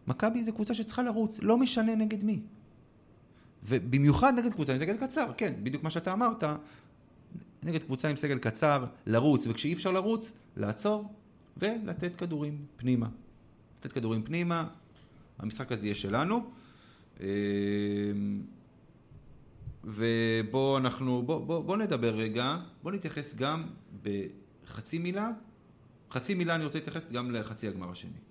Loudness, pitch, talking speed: -32 LUFS, 150 Hz, 130 wpm